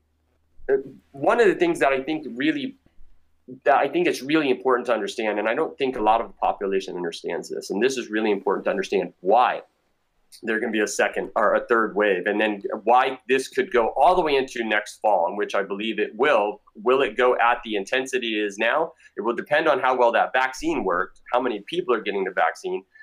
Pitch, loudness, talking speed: 130 Hz, -23 LUFS, 225 wpm